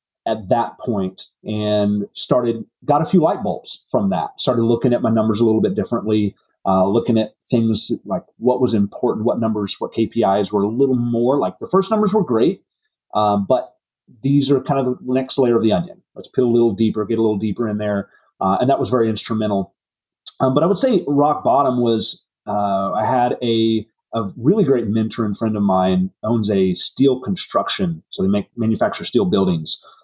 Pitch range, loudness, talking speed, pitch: 105-130 Hz, -19 LUFS, 205 wpm, 115 Hz